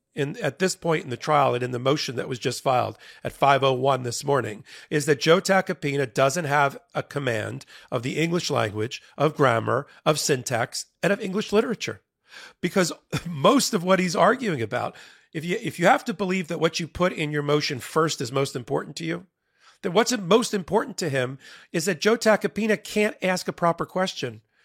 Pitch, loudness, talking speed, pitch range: 160 Hz, -24 LUFS, 195 wpm, 135-190 Hz